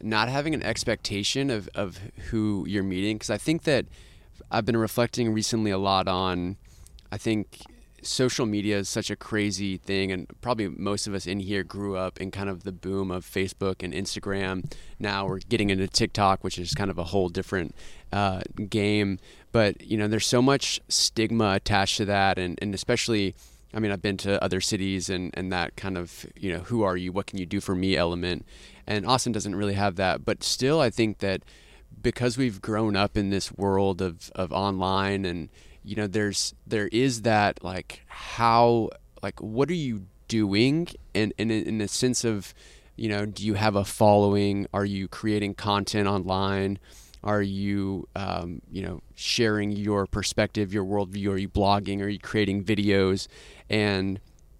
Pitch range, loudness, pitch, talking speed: 95-110 Hz, -26 LUFS, 100 Hz, 185 wpm